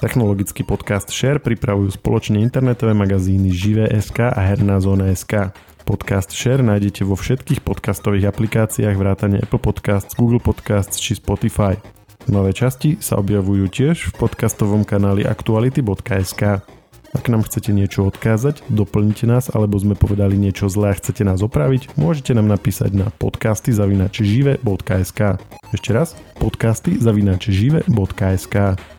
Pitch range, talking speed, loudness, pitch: 100-115 Hz, 120 wpm, -18 LUFS, 105 Hz